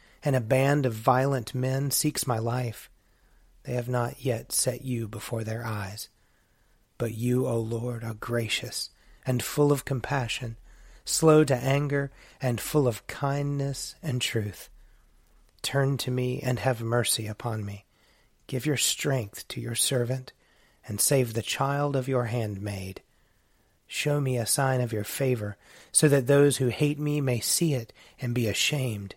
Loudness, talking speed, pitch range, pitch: -27 LUFS, 160 wpm, 115-140 Hz, 125 Hz